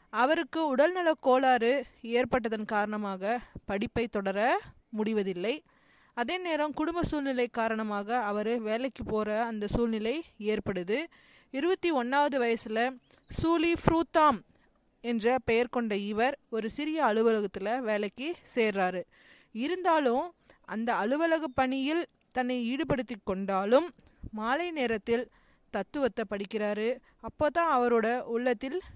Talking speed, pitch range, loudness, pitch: 95 wpm, 220-285 Hz, -30 LUFS, 240 Hz